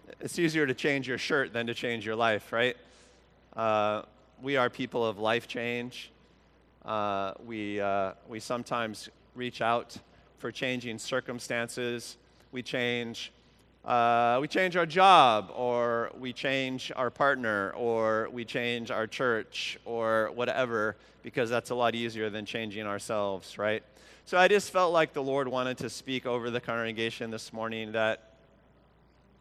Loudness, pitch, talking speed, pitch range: -29 LUFS, 120 Hz, 150 wpm, 110-125 Hz